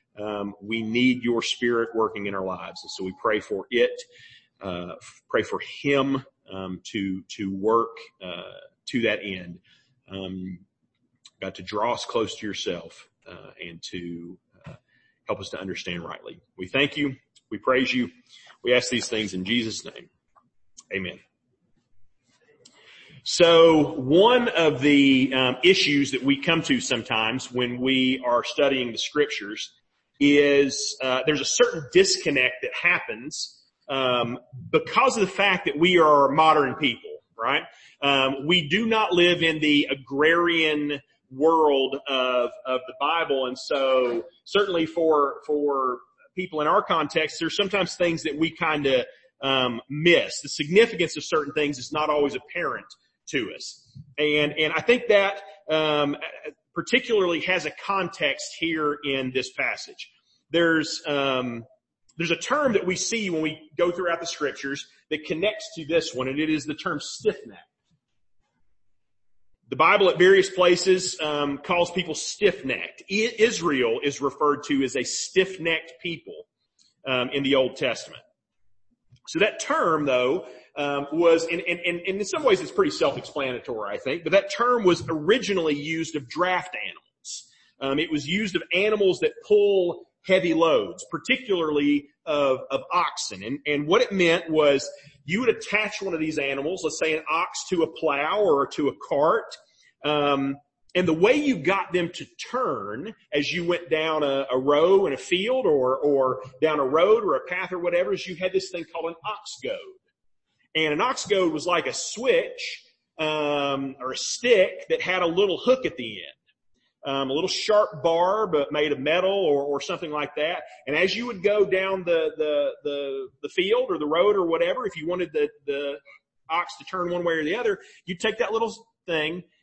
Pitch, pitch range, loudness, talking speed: 155 Hz, 135-190 Hz, -23 LUFS, 170 wpm